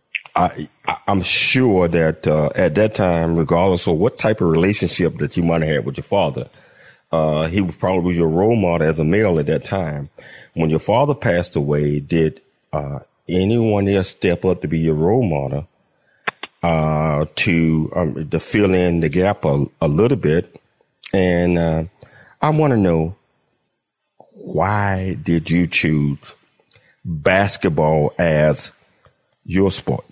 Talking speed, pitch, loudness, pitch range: 155 wpm, 85 Hz, -18 LUFS, 80-95 Hz